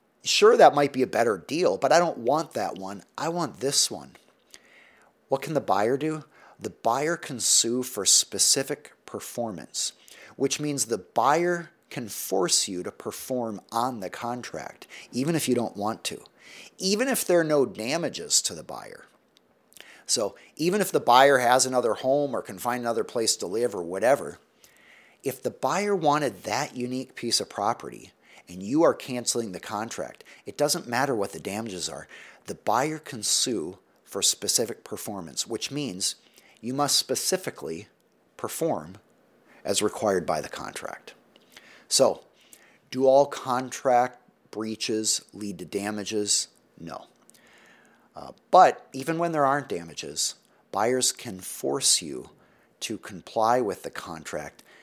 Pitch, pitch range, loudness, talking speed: 130 Hz, 115-150 Hz, -25 LUFS, 150 wpm